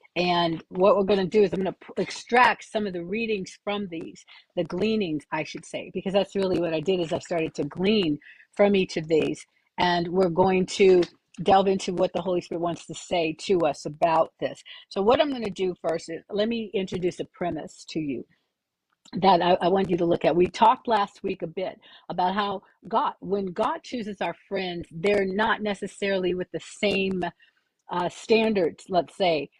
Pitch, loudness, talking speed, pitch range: 190 Hz, -25 LUFS, 205 wpm, 175-205 Hz